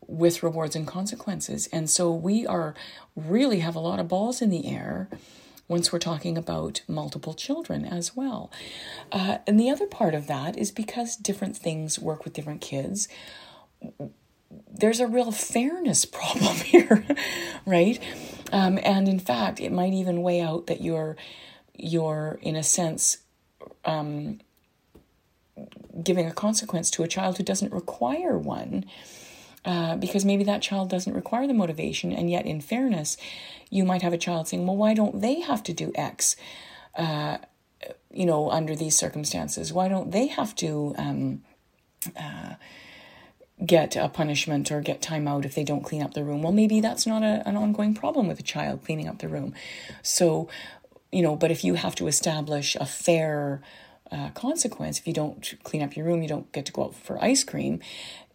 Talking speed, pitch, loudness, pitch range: 175 wpm, 175 Hz, -26 LUFS, 155-210 Hz